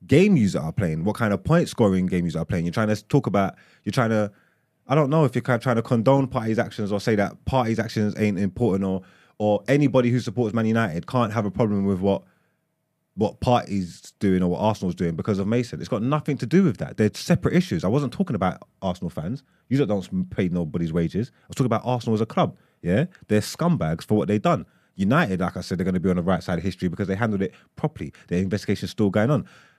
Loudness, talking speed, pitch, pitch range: -23 LUFS, 245 wpm, 110 Hz, 95-135 Hz